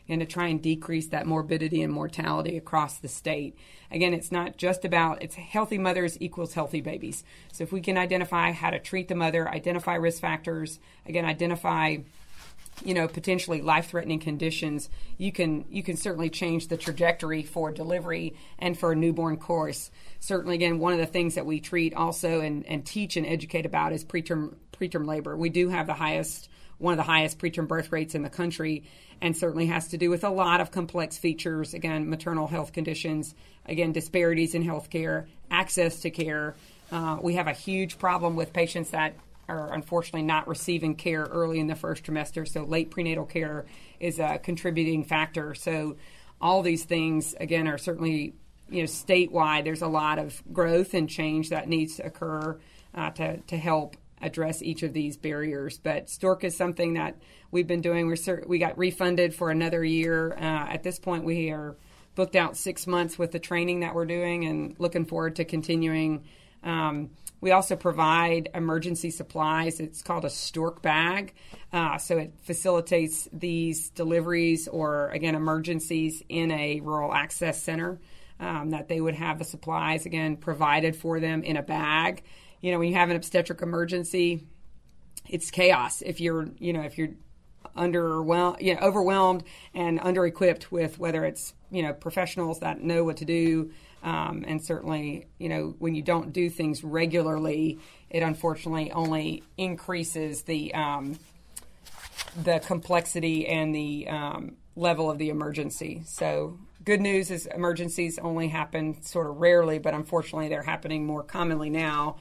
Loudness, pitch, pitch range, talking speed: -28 LUFS, 165 Hz, 155-175 Hz, 175 wpm